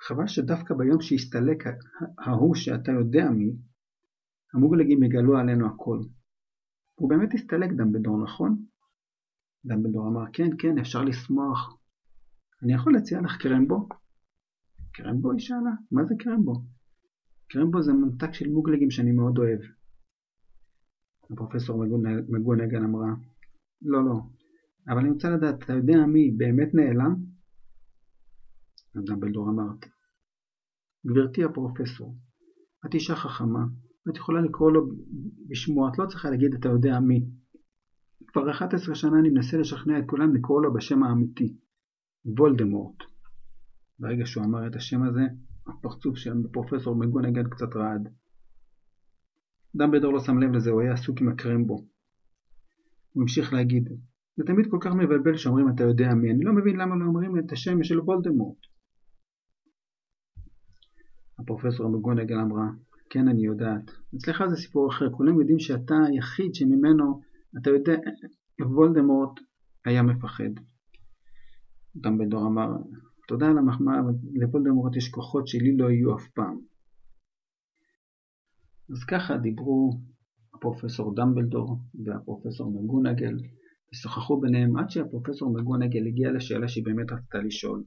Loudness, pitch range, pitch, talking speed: -25 LUFS, 115-155 Hz, 125 Hz, 130 wpm